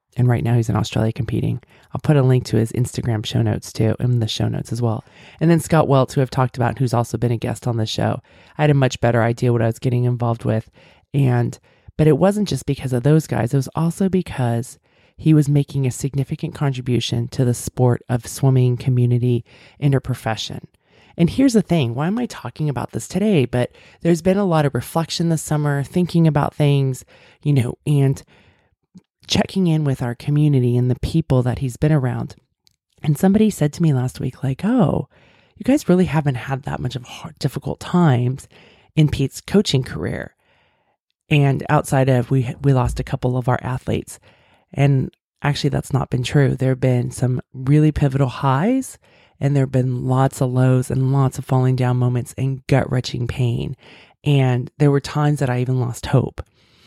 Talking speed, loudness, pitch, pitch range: 200 wpm, -19 LUFS, 130 Hz, 125-150 Hz